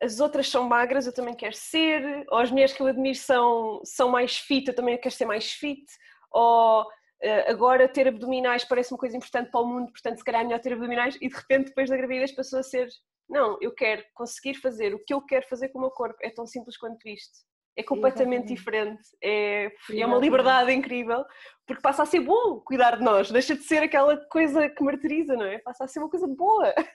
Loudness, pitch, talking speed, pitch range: -25 LUFS, 255 Hz, 225 wpm, 240-275 Hz